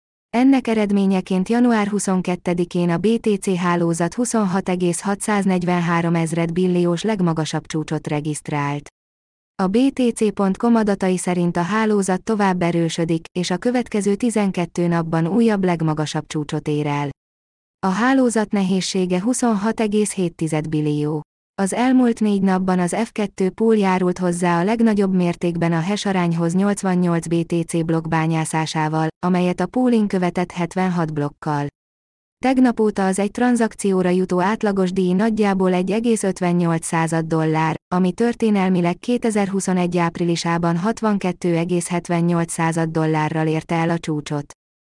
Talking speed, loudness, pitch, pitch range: 110 wpm, -19 LUFS, 180 Hz, 165-205 Hz